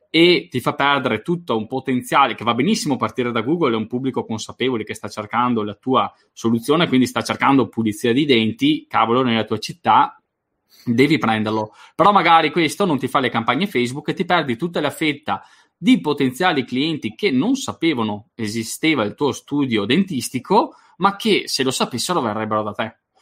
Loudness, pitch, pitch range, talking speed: -19 LUFS, 125 Hz, 110-155 Hz, 180 wpm